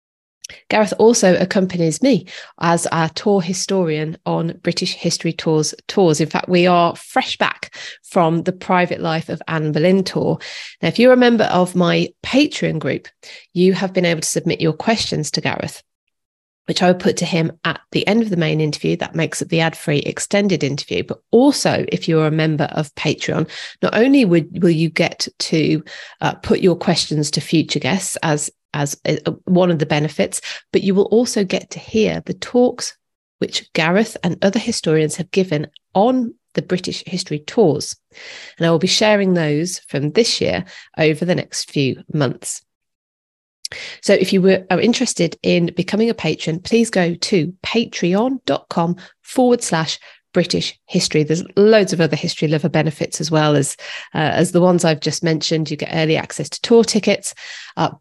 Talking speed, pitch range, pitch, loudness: 180 wpm, 160-195 Hz, 175 Hz, -17 LUFS